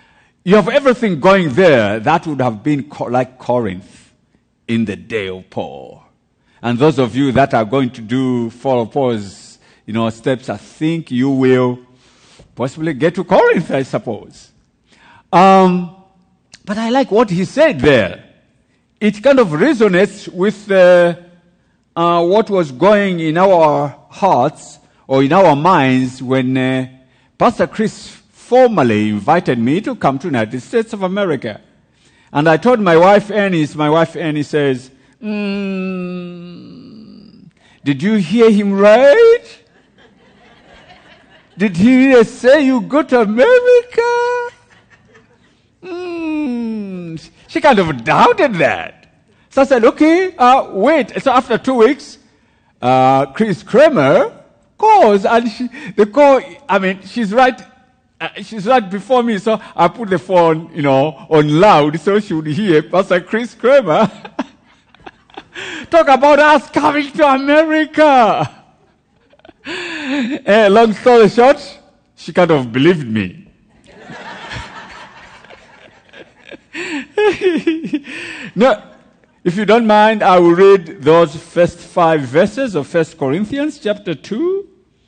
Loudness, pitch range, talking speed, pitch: -13 LUFS, 150-250 Hz, 130 wpm, 195 Hz